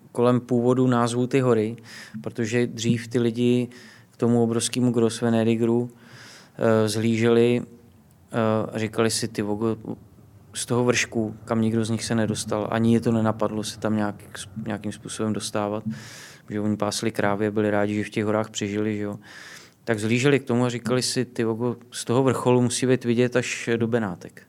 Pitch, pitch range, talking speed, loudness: 115 Hz, 110-120 Hz, 165 wpm, -24 LUFS